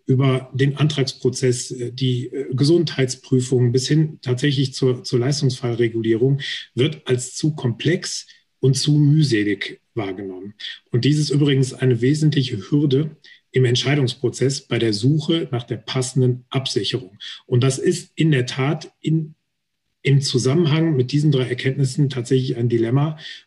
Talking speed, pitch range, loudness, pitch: 130 wpm, 125-145 Hz, -20 LUFS, 130 Hz